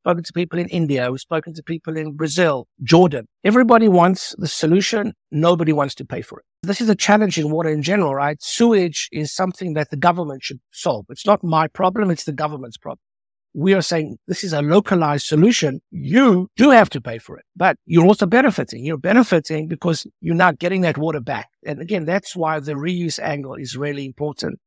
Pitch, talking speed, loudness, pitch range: 165 Hz, 205 wpm, -18 LUFS, 150-185 Hz